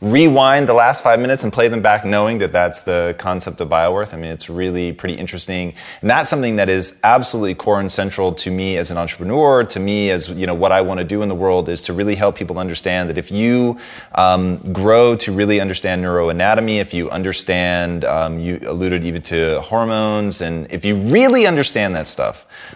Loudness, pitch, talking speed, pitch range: -16 LUFS, 95 Hz, 210 wpm, 90-105 Hz